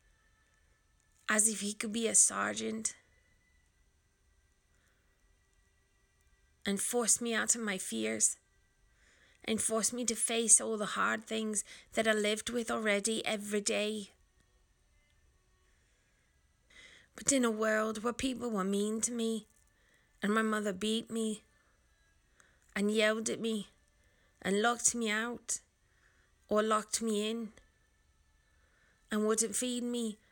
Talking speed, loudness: 120 wpm, -32 LUFS